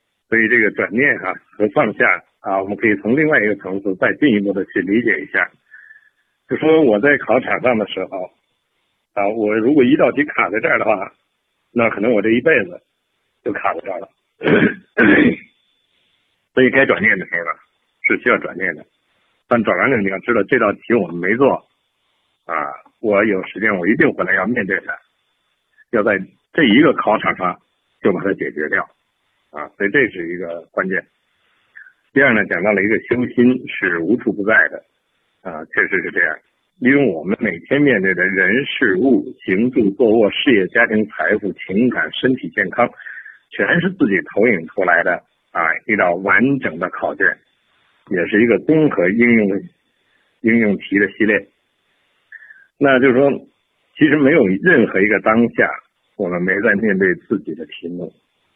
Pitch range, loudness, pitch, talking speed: 105-140 Hz, -16 LUFS, 120 Hz, 250 characters per minute